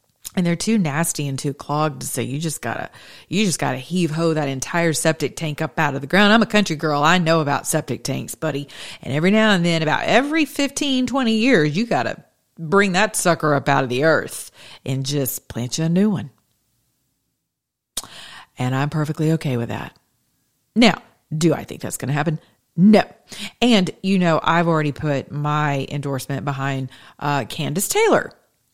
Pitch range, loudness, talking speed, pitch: 140-185 Hz, -20 LUFS, 180 wpm, 155 Hz